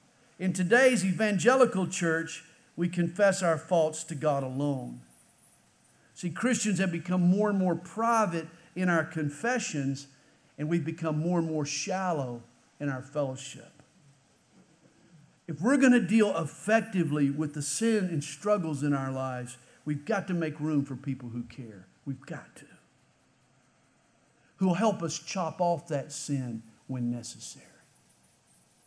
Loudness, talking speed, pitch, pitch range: -29 LUFS, 140 wpm, 160 Hz, 140-185 Hz